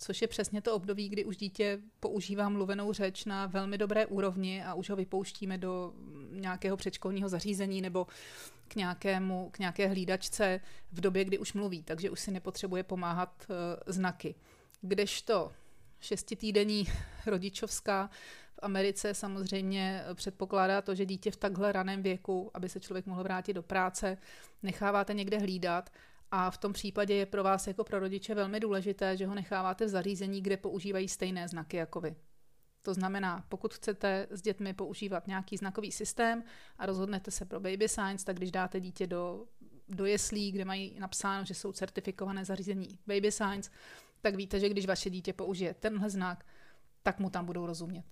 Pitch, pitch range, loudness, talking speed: 195 Hz, 185-205 Hz, -35 LUFS, 165 wpm